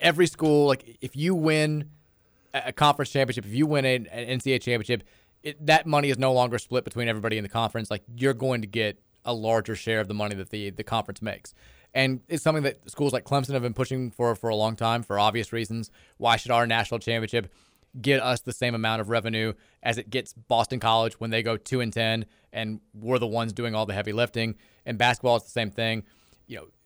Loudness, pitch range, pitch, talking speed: -26 LUFS, 110-130 Hz, 115 Hz, 225 wpm